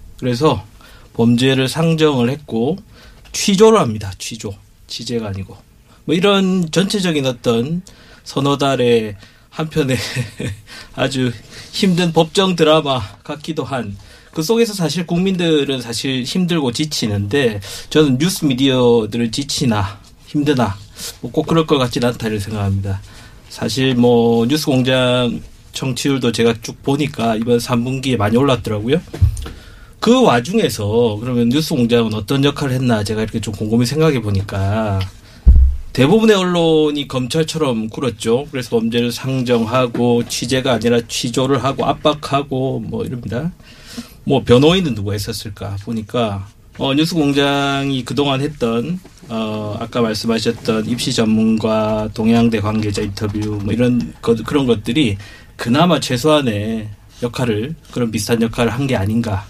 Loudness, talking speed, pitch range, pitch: -17 LUFS, 295 characters per minute, 110-145 Hz, 120 Hz